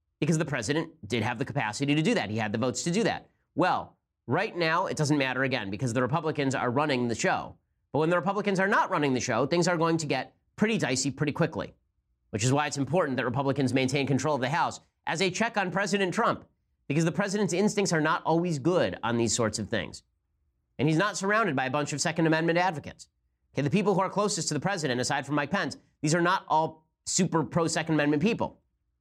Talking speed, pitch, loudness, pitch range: 235 wpm, 150 Hz, -27 LUFS, 130-175 Hz